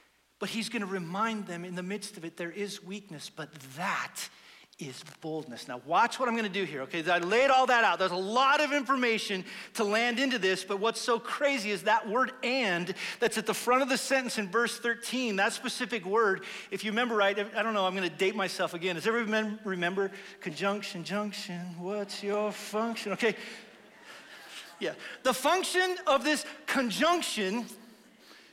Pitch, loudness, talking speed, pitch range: 210 Hz, -30 LUFS, 190 wpm, 190-240 Hz